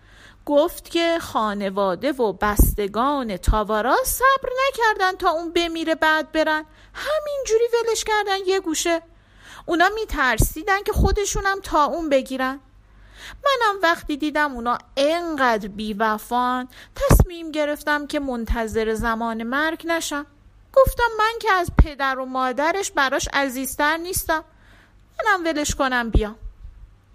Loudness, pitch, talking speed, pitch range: -21 LUFS, 300 Hz, 115 wpm, 255-350 Hz